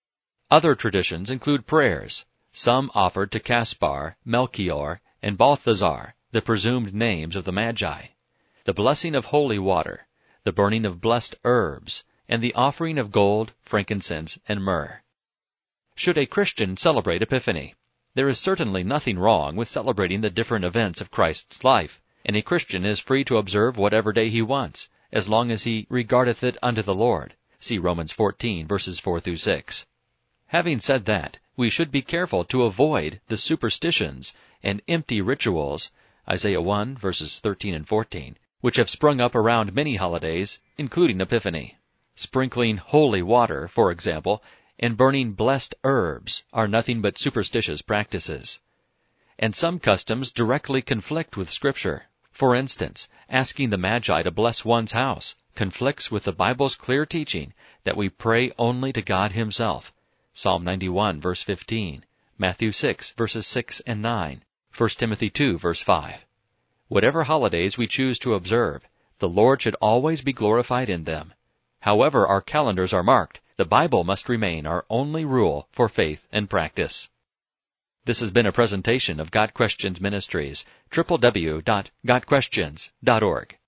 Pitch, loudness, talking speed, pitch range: 110 Hz, -23 LUFS, 150 wpm, 95-125 Hz